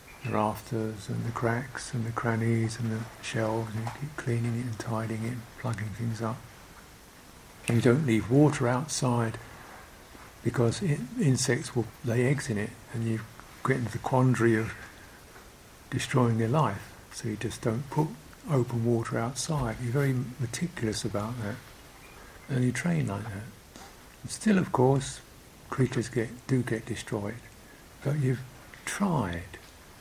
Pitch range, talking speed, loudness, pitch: 110-130 Hz, 155 wpm, -30 LUFS, 115 Hz